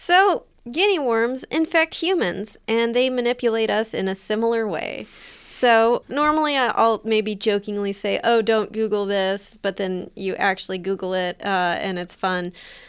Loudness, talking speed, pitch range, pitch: -21 LUFS, 155 wpm, 195-245 Hz, 220 Hz